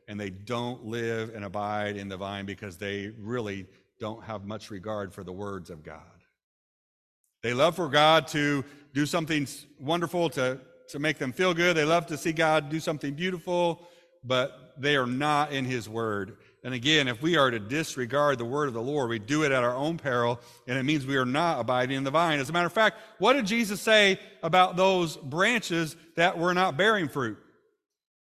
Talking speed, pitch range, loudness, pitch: 205 wpm, 115-170 Hz, -27 LUFS, 145 Hz